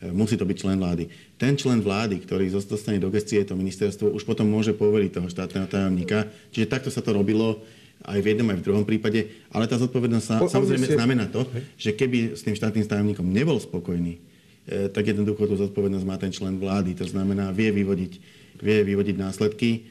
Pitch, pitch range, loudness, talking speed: 105 Hz, 95-110 Hz, -24 LUFS, 185 wpm